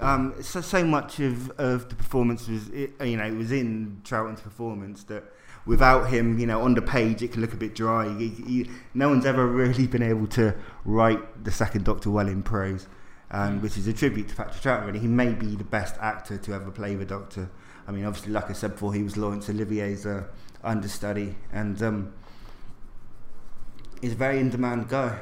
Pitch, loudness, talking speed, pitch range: 110 Hz, -27 LUFS, 210 wpm, 105-125 Hz